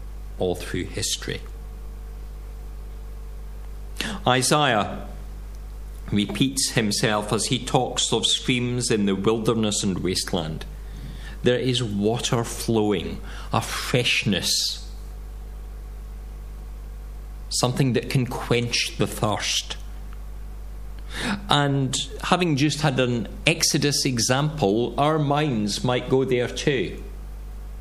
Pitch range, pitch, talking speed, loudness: 105-135 Hz, 120 Hz, 90 wpm, -23 LUFS